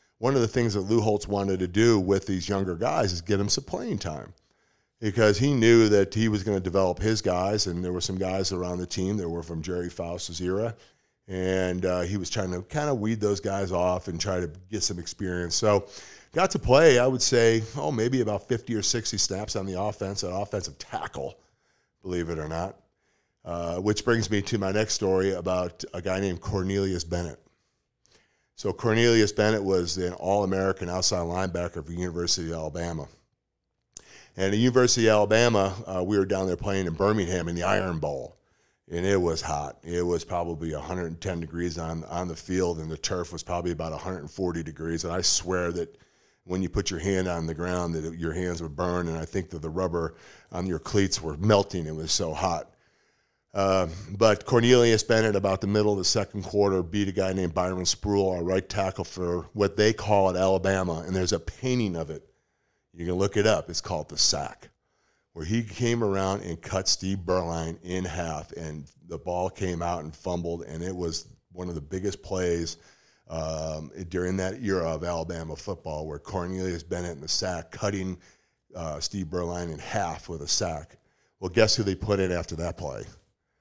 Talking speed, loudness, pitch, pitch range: 205 wpm, -27 LUFS, 95 Hz, 85-100 Hz